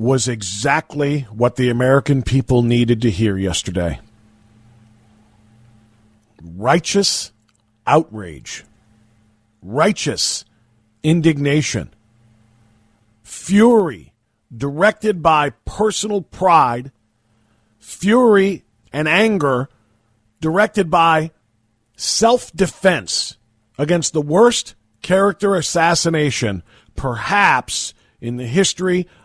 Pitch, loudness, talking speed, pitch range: 120 Hz, -17 LUFS, 70 wpm, 110-165 Hz